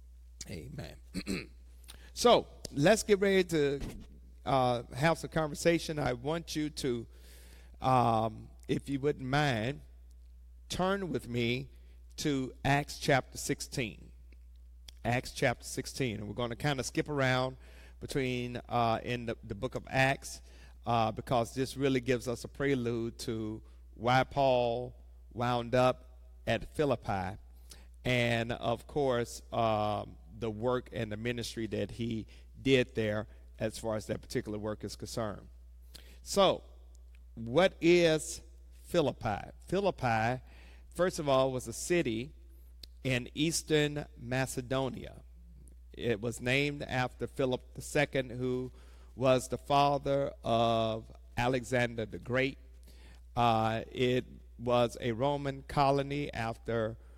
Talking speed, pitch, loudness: 120 wpm, 120 Hz, -32 LUFS